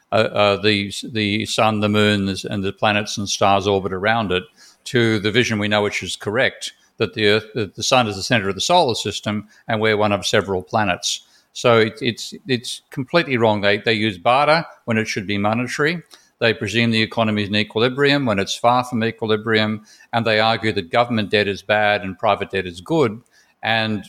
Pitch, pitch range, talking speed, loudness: 110 Hz, 105-115 Hz, 205 wpm, -19 LUFS